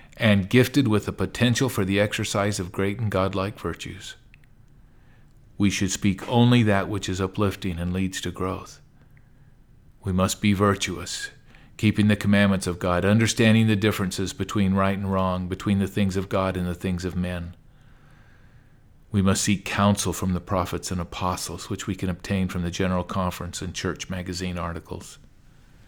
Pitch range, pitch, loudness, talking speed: 90-105 Hz, 95 Hz, -24 LUFS, 165 wpm